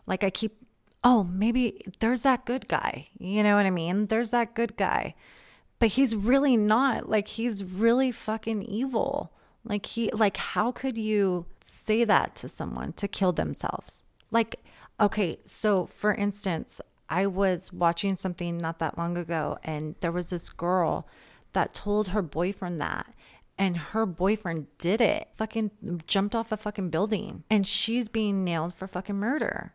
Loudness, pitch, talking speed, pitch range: -28 LUFS, 205 Hz, 165 wpm, 180-225 Hz